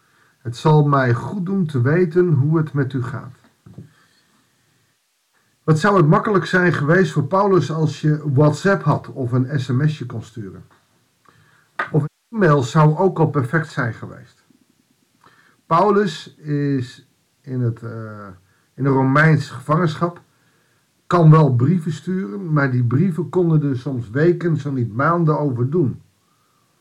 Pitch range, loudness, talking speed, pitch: 130-170 Hz, -18 LUFS, 140 wpm, 150 Hz